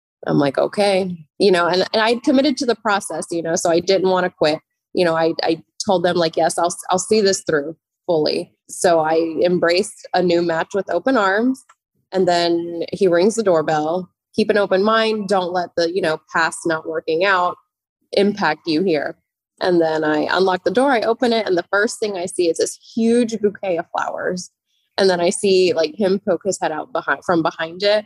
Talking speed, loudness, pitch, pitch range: 215 wpm, -18 LUFS, 180 Hz, 165-200 Hz